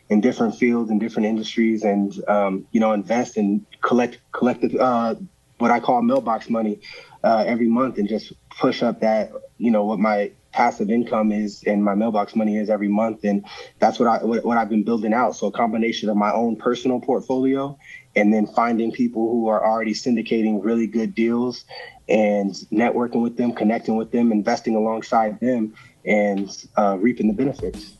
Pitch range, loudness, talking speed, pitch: 105-120 Hz, -21 LUFS, 185 wpm, 110 Hz